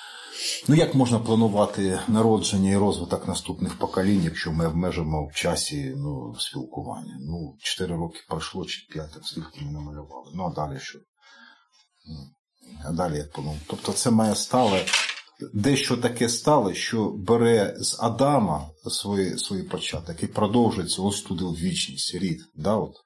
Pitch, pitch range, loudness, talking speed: 100 Hz, 80-115 Hz, -25 LUFS, 145 wpm